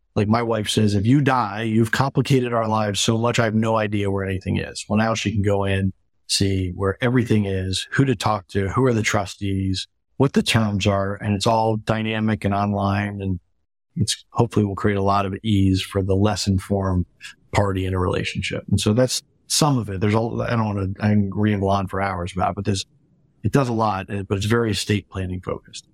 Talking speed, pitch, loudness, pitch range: 220 wpm, 105 Hz, -21 LUFS, 95-115 Hz